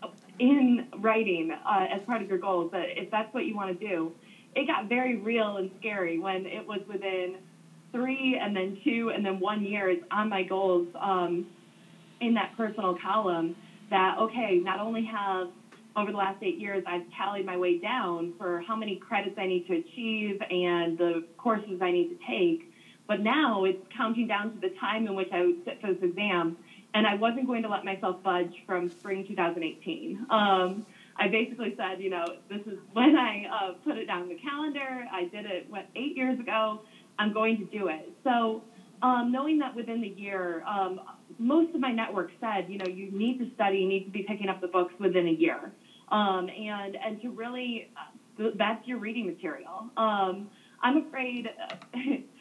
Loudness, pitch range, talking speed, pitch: -30 LUFS, 185-230 Hz, 195 wpm, 205 Hz